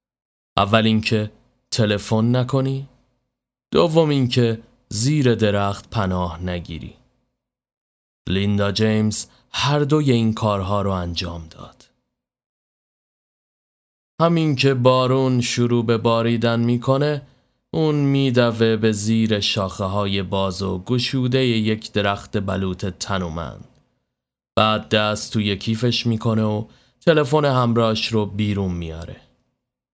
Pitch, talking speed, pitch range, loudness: 110 Hz, 100 wpm, 100-125 Hz, -20 LUFS